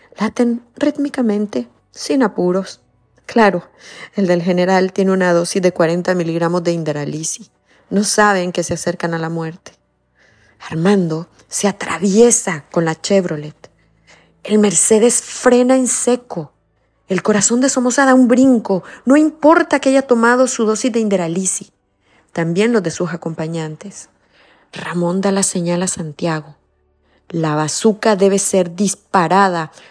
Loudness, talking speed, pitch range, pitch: -15 LUFS, 135 wpm, 165-220 Hz, 190 Hz